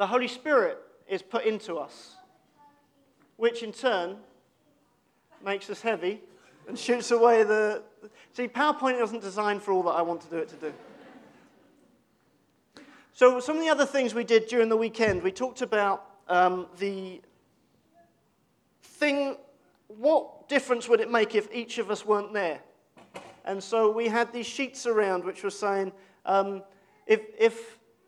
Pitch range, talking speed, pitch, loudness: 200-275 Hz, 155 wpm, 230 Hz, -27 LUFS